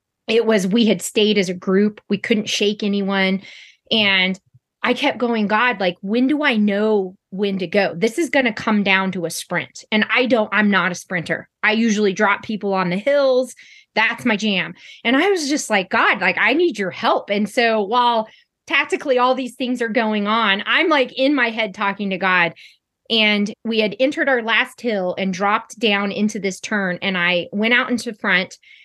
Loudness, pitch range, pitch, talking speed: -18 LUFS, 195-240 Hz, 215 Hz, 205 wpm